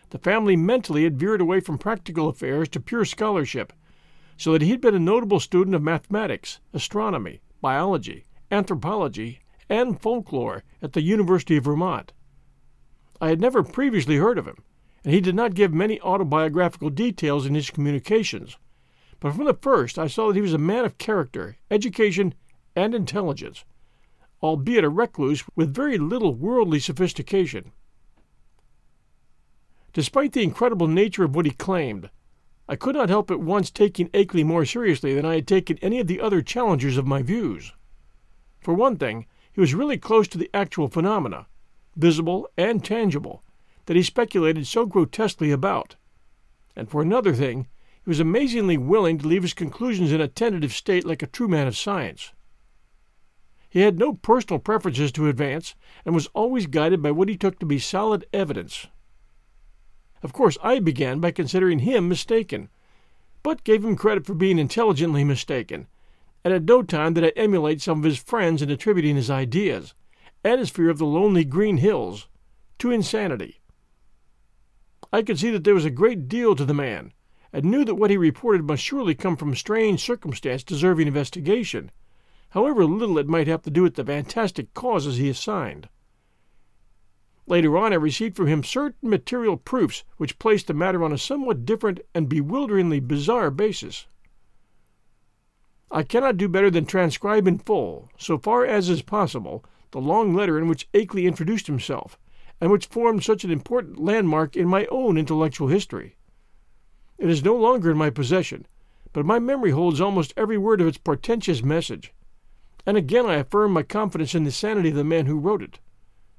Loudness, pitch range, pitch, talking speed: -22 LUFS, 150-210 Hz, 175 Hz, 170 wpm